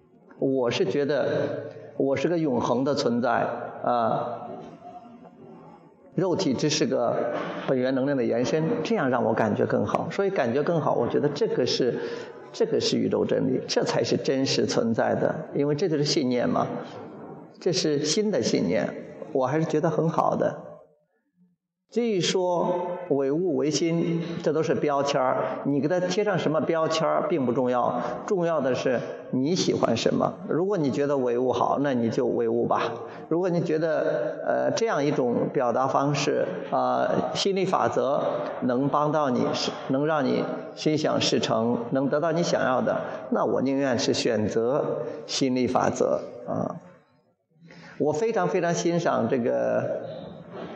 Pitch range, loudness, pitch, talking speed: 140-180 Hz, -25 LUFS, 160 Hz, 225 characters per minute